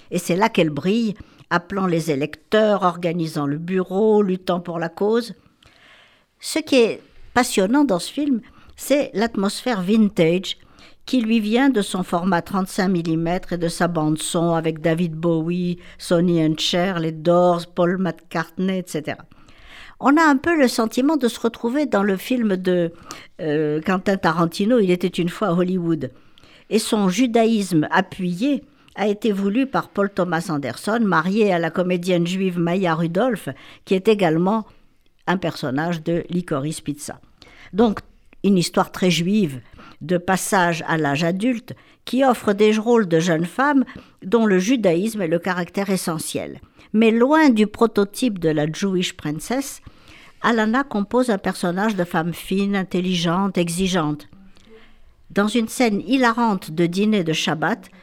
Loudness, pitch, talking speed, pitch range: -20 LUFS, 185 Hz, 150 wpm, 170-220 Hz